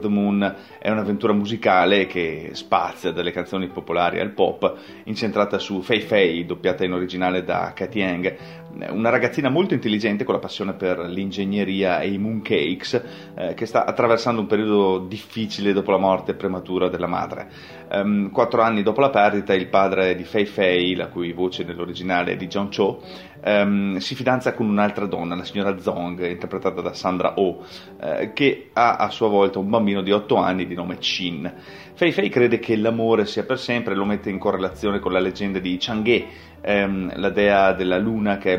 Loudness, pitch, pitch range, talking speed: -21 LUFS, 100 Hz, 90-105 Hz, 180 wpm